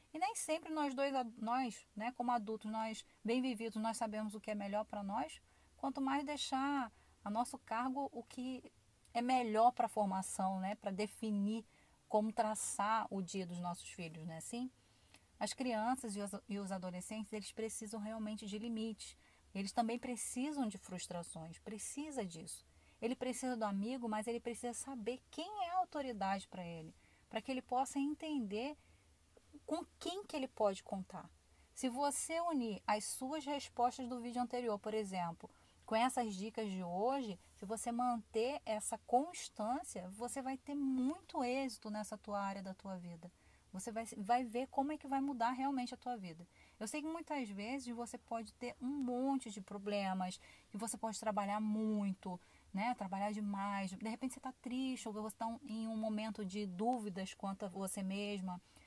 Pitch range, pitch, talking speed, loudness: 205-255 Hz, 225 Hz, 175 wpm, -41 LUFS